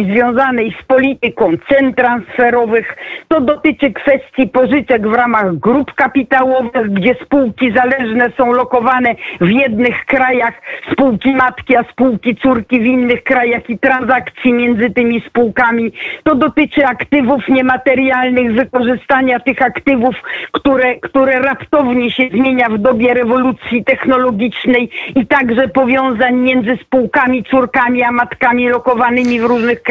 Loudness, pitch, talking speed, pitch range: -12 LUFS, 255 Hz, 125 wpm, 240-265 Hz